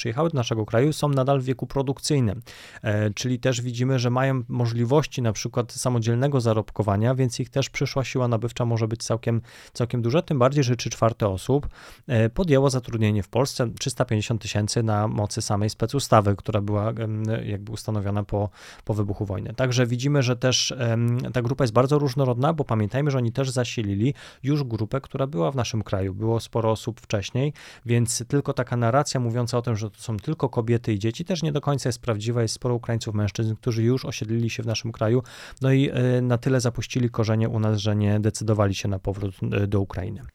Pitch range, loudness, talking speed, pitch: 110-130 Hz, -24 LUFS, 195 wpm, 120 Hz